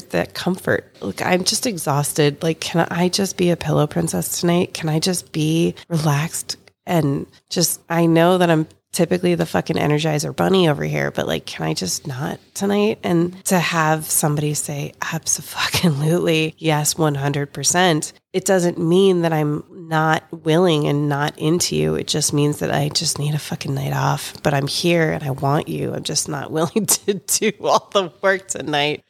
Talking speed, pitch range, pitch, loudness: 180 wpm, 150-175 Hz, 160 Hz, -19 LUFS